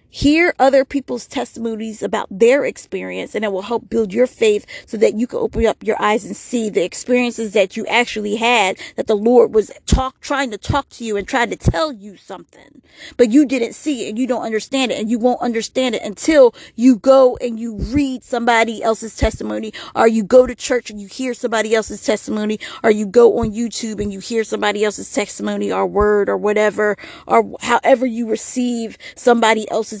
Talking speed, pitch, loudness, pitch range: 205 wpm, 230 Hz, -17 LUFS, 215-255 Hz